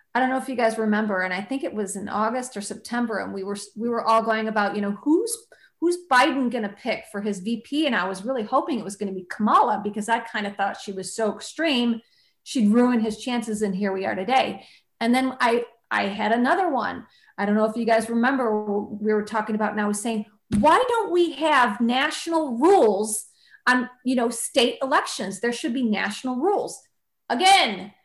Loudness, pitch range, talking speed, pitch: -23 LUFS, 210-260 Hz, 220 wpm, 230 Hz